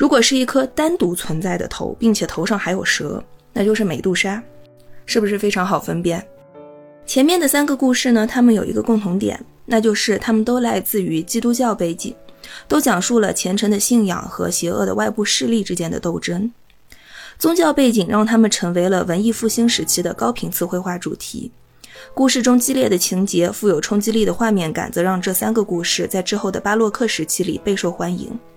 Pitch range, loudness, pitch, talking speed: 180-235 Hz, -18 LUFS, 210 Hz, 305 characters per minute